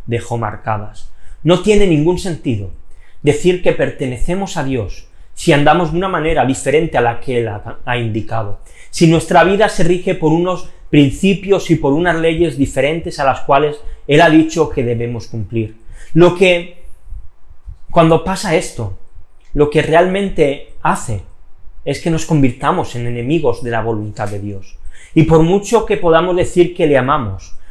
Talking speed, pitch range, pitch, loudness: 160 wpm, 110-170 Hz, 145 Hz, -14 LUFS